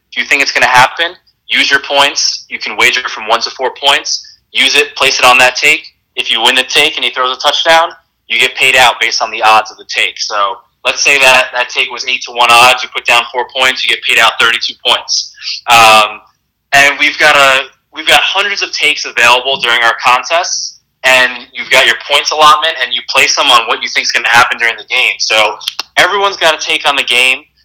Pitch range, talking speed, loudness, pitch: 120-150 Hz, 240 wpm, -8 LUFS, 130 Hz